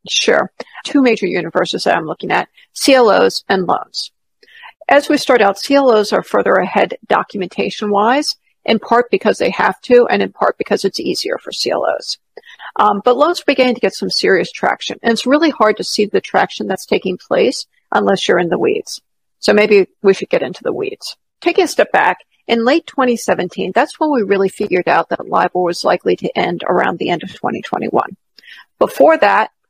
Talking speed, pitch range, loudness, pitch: 190 wpm, 210-315 Hz, -15 LUFS, 245 Hz